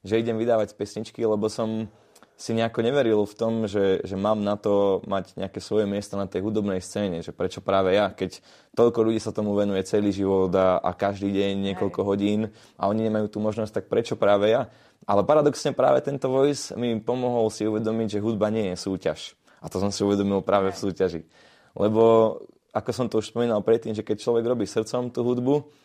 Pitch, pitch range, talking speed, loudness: 105 Hz, 100-115 Hz, 200 wpm, -24 LUFS